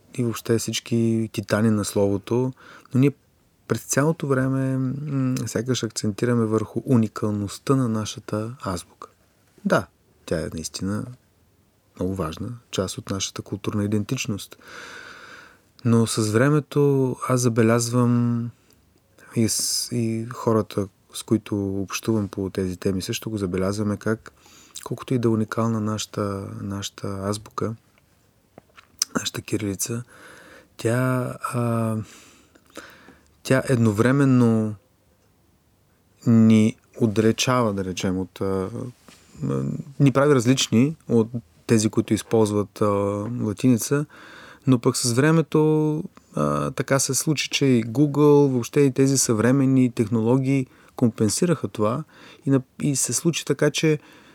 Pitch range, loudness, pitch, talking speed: 105-130 Hz, -23 LUFS, 115 Hz, 115 wpm